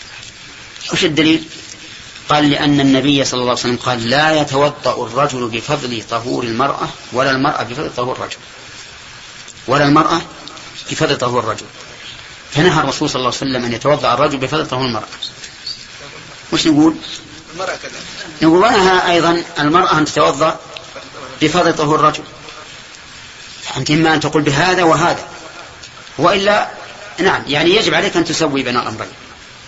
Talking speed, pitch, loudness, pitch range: 130 wpm, 150 Hz, -14 LUFS, 130-160 Hz